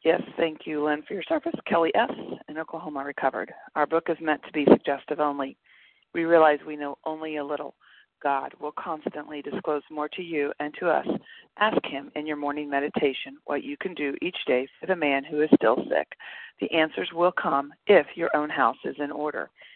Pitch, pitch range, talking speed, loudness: 150 Hz, 145-160 Hz, 205 wpm, -26 LUFS